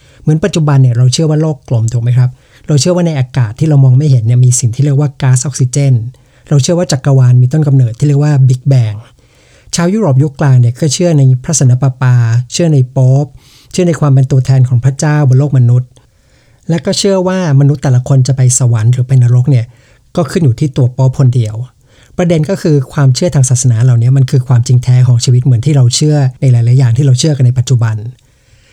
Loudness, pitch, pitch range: -9 LUFS, 130 Hz, 125-145 Hz